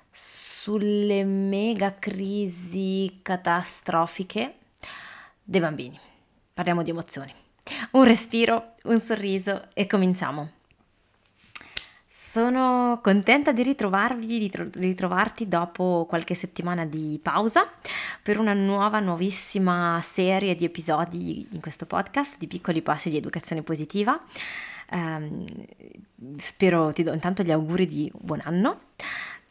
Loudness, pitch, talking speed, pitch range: -25 LUFS, 185 Hz, 110 wpm, 170-210 Hz